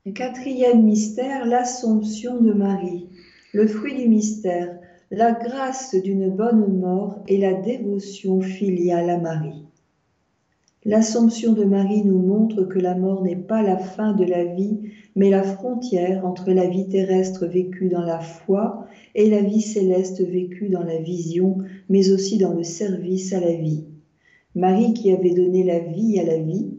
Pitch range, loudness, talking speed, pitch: 180-215 Hz, -21 LUFS, 160 wpm, 195 Hz